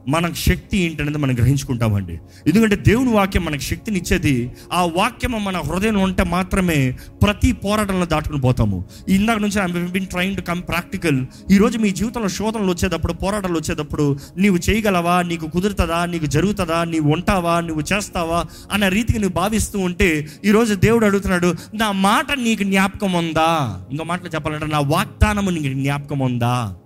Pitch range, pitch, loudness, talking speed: 150-200 Hz, 175 Hz, -19 LUFS, 145 wpm